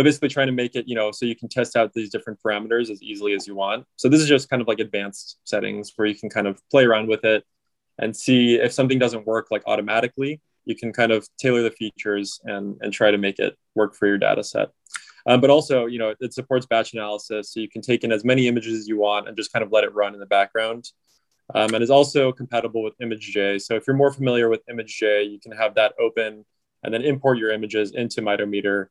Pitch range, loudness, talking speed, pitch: 105-125 Hz, -22 LUFS, 250 wpm, 115 Hz